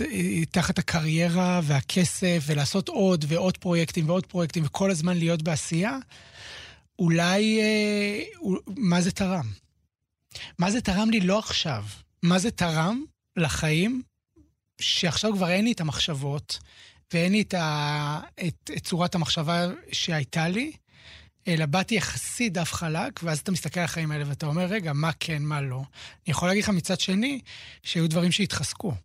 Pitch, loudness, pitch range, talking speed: 175 Hz, -26 LUFS, 155-190 Hz, 150 wpm